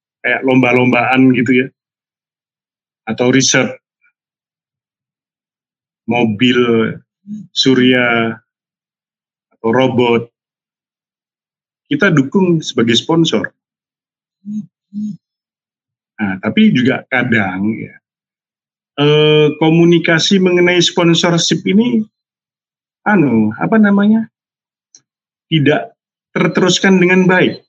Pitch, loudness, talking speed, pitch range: 150 Hz, -12 LUFS, 65 wpm, 125-185 Hz